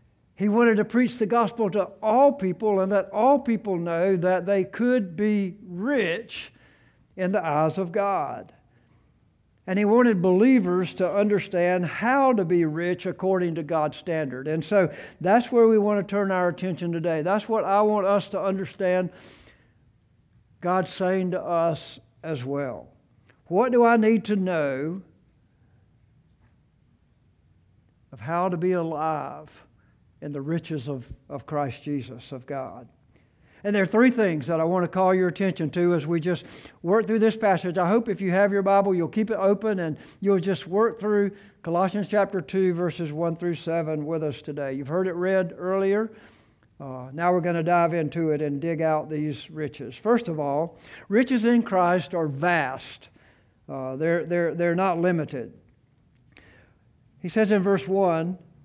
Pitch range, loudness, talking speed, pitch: 160-200 Hz, -24 LUFS, 170 wpm, 180 Hz